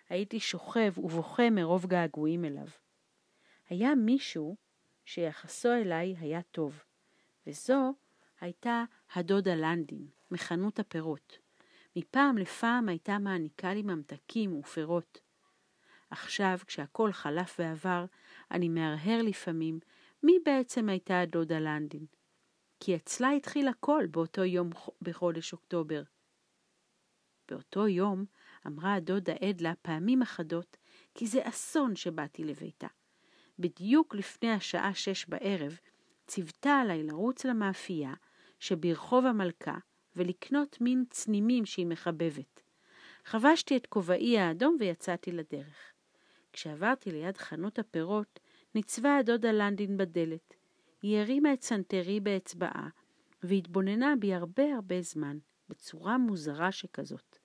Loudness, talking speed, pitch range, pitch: -32 LUFS, 105 wpm, 170-225 Hz, 185 Hz